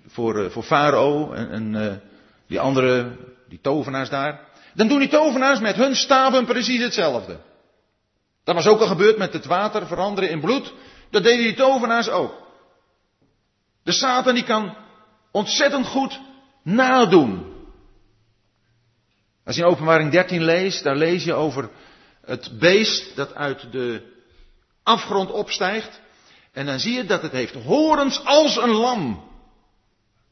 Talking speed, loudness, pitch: 140 wpm, -19 LUFS, 190 Hz